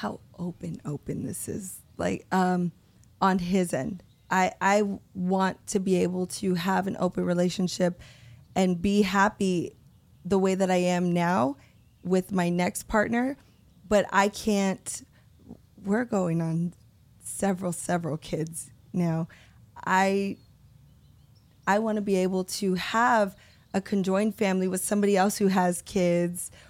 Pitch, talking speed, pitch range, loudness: 185 Hz, 135 wpm, 175-195 Hz, -27 LUFS